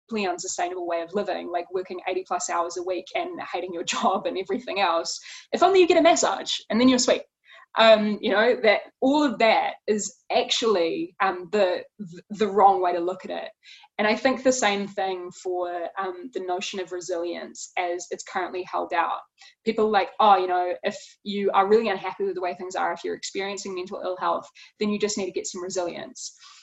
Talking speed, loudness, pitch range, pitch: 210 wpm, -24 LUFS, 180-225 Hz, 195 Hz